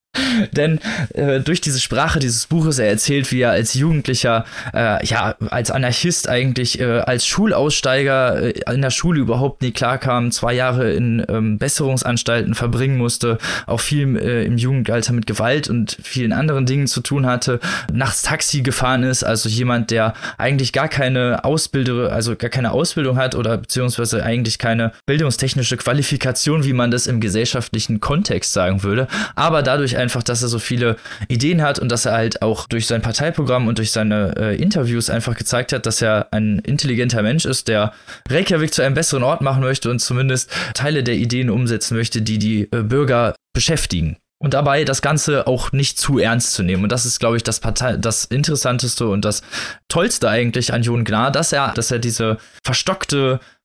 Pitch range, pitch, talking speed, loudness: 115-135 Hz, 125 Hz, 180 wpm, -18 LUFS